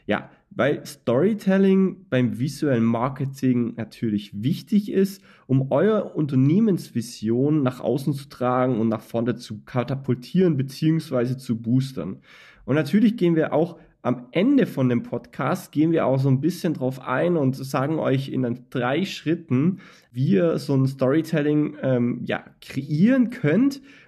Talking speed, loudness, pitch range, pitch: 140 wpm, -23 LUFS, 125-170 Hz, 140 Hz